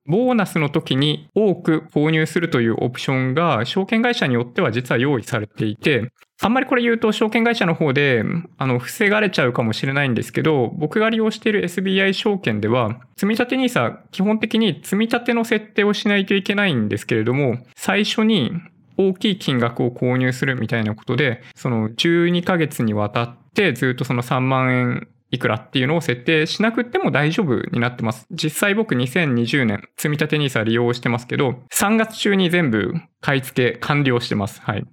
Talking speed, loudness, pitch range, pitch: 380 characters per minute, -19 LUFS, 125-200 Hz, 155 Hz